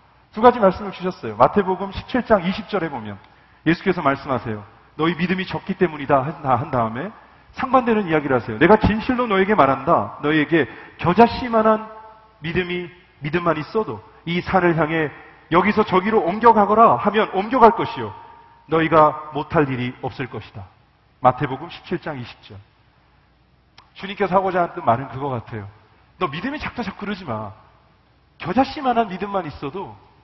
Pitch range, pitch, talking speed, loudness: 135-205 Hz, 170 Hz, 325 characters per minute, -20 LUFS